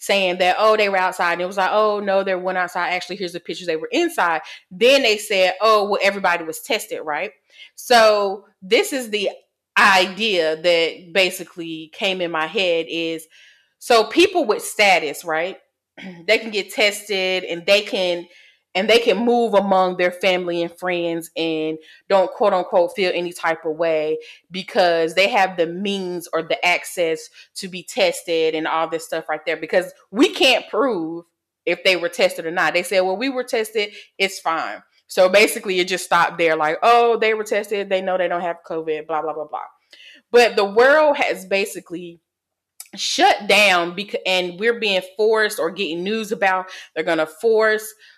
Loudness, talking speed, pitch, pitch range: -19 LUFS, 185 wpm, 185 Hz, 170-215 Hz